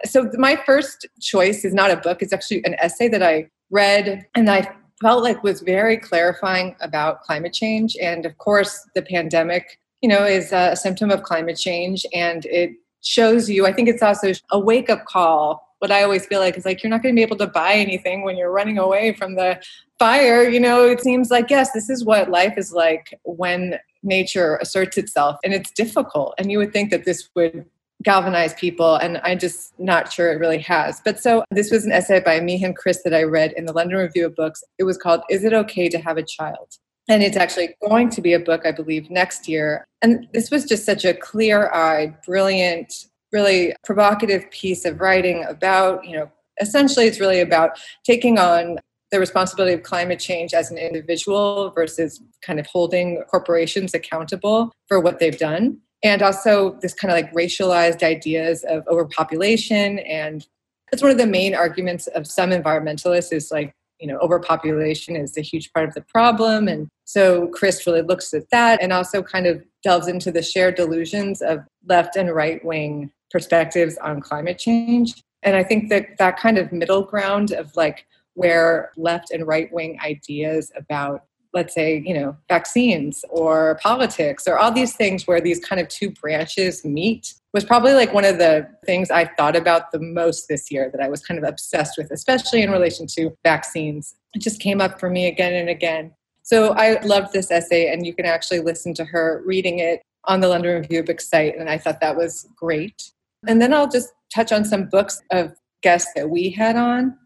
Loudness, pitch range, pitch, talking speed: -19 LUFS, 165-205 Hz, 180 Hz, 200 wpm